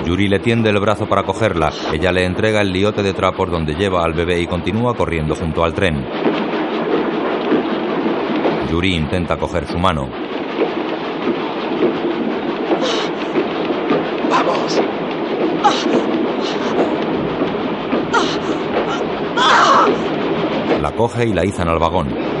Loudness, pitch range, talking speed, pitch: -17 LUFS, 85-105 Hz, 100 wpm, 90 Hz